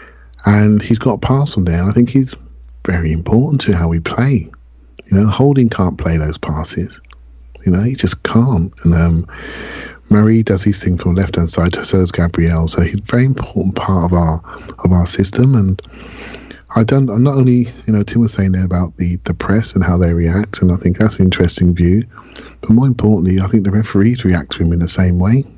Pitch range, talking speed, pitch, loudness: 85-115 Hz, 225 wpm, 95 Hz, -14 LUFS